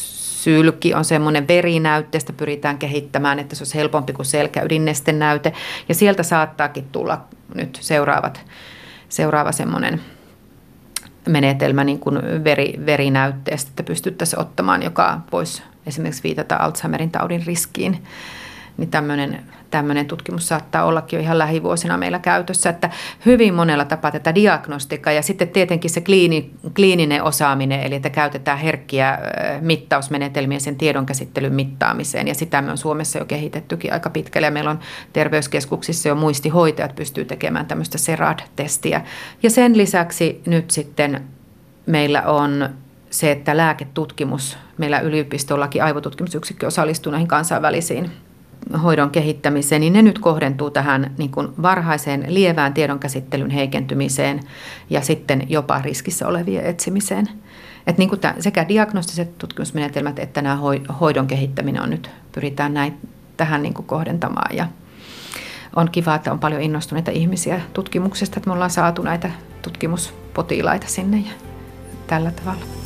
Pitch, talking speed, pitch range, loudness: 155 Hz, 130 wpm, 145-170 Hz, -19 LUFS